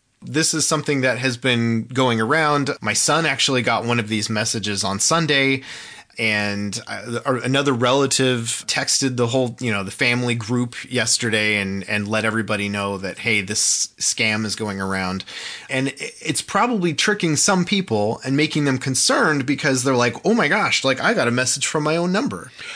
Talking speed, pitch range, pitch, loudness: 175 wpm, 110-145 Hz, 125 Hz, -19 LUFS